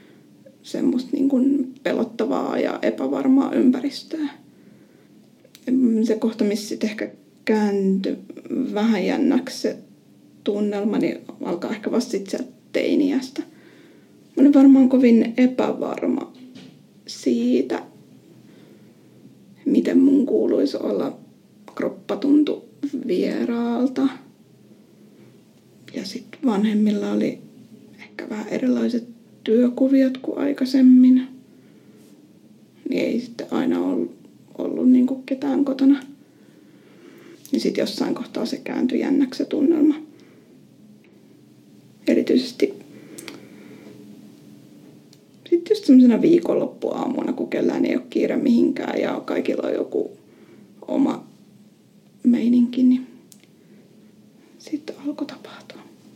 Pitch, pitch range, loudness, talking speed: 260 Hz, 230-280 Hz, -21 LUFS, 90 wpm